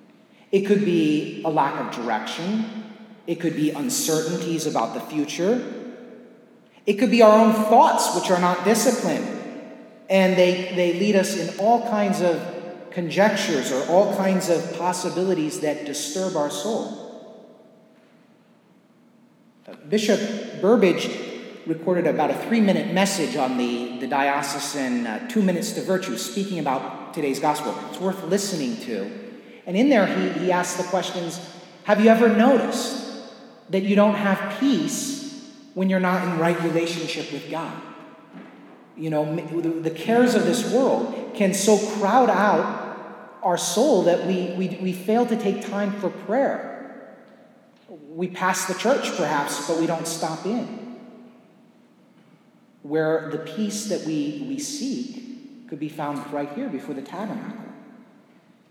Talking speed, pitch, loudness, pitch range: 145 wpm, 195 Hz, -22 LUFS, 170-230 Hz